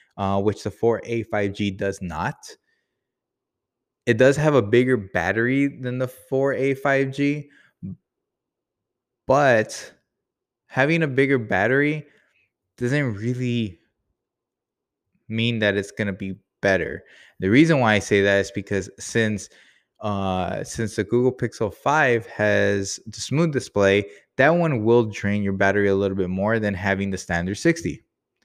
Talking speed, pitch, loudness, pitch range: 135 wpm, 110 Hz, -22 LUFS, 100-130 Hz